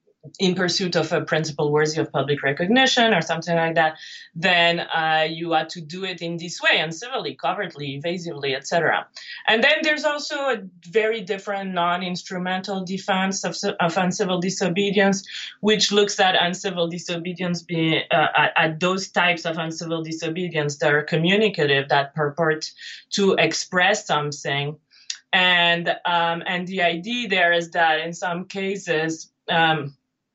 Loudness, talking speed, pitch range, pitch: -21 LUFS, 150 wpm, 160-190 Hz, 175 Hz